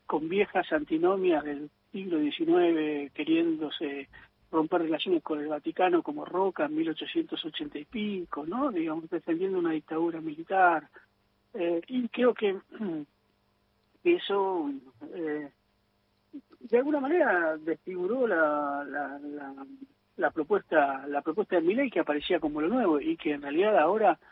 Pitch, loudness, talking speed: 175 Hz, -29 LUFS, 135 wpm